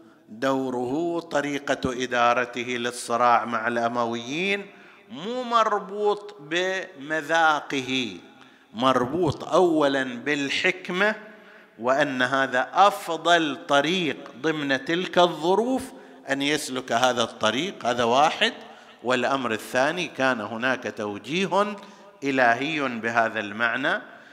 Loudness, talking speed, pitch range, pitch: -24 LUFS, 80 wpm, 125-185 Hz, 140 Hz